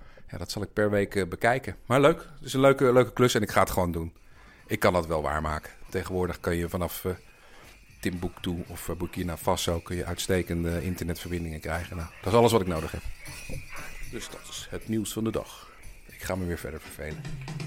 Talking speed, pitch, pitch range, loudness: 210 wpm, 90 Hz, 85-110 Hz, -28 LUFS